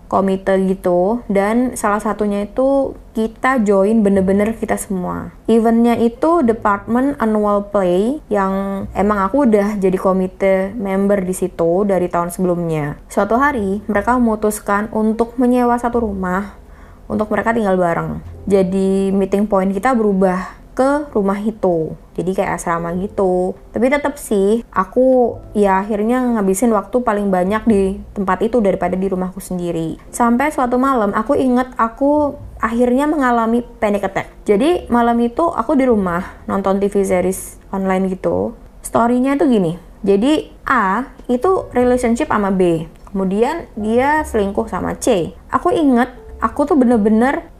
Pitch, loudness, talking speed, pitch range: 210 Hz, -16 LUFS, 135 wpm, 190-240 Hz